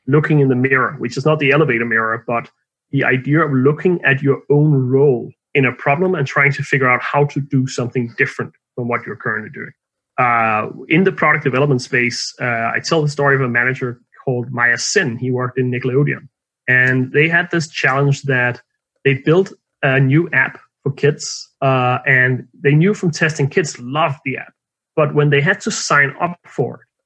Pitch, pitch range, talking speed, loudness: 140 Hz, 125-150 Hz, 200 wpm, -16 LUFS